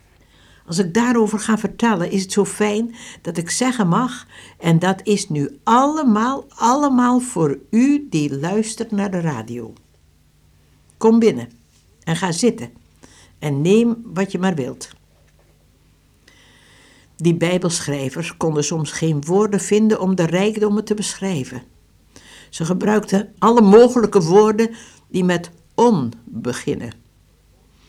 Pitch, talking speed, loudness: 180 Hz, 125 wpm, -18 LUFS